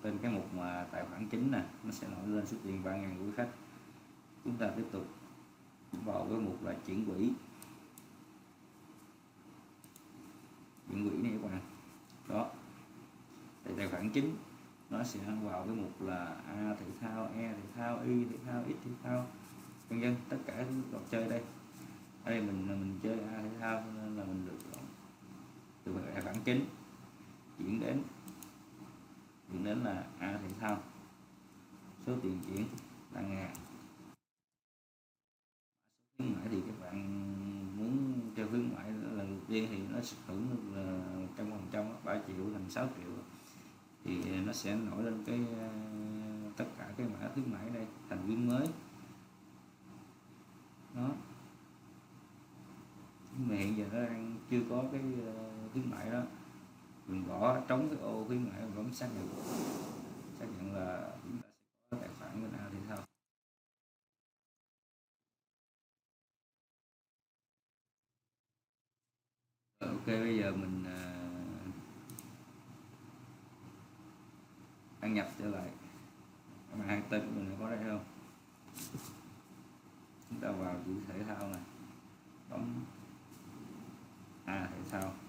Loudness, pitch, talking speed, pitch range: -40 LUFS, 100 Hz, 140 wpm, 80-110 Hz